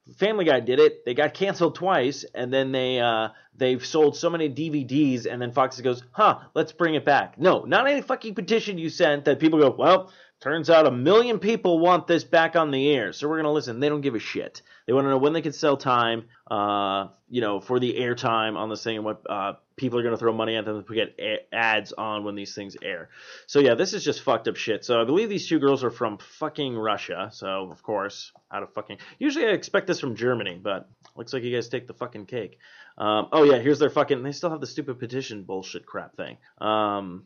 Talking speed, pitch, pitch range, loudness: 240 wpm, 135 Hz, 115-160 Hz, -24 LUFS